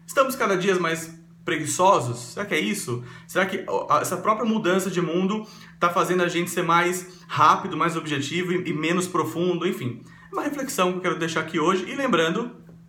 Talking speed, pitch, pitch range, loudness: 185 wpm, 175 Hz, 165-190 Hz, -23 LUFS